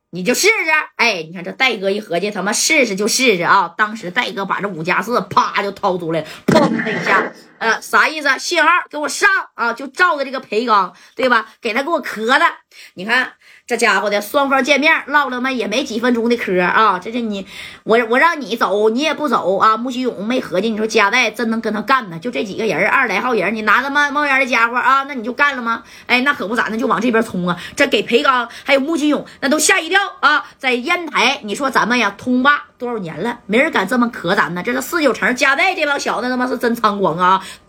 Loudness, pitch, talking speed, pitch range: -16 LUFS, 245 Hz, 330 characters per minute, 215-280 Hz